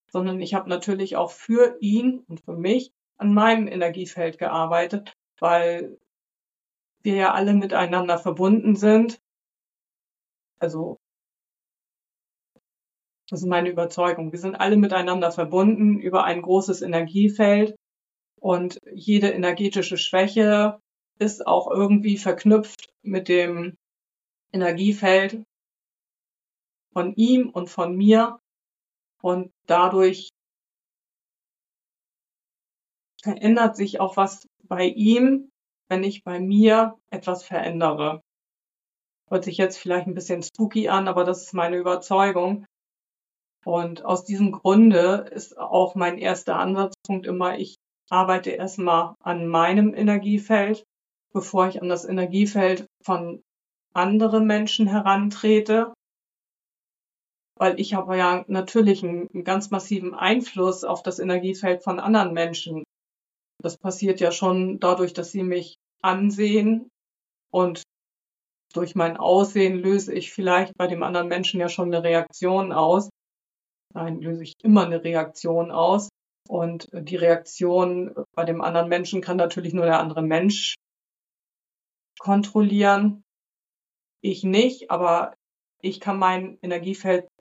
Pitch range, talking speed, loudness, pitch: 175-205 Hz, 120 wpm, -22 LUFS, 185 Hz